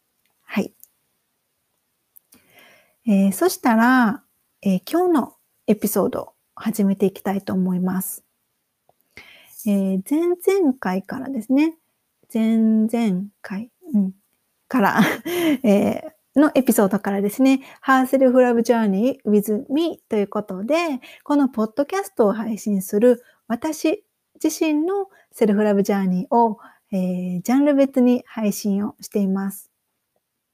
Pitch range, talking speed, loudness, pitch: 205-280 Hz, 265 characters per minute, -20 LUFS, 225 Hz